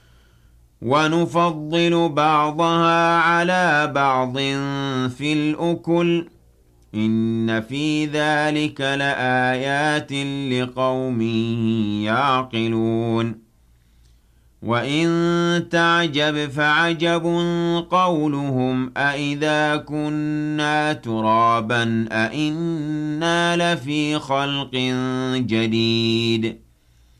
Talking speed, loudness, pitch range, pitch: 50 wpm, -20 LUFS, 115-155 Hz, 140 Hz